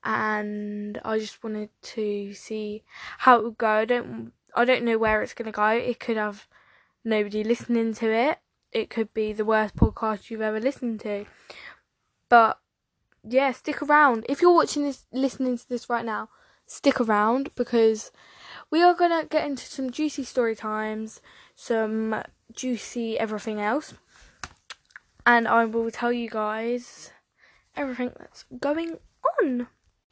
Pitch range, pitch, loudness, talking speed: 215-260 Hz, 230 Hz, -25 LUFS, 150 wpm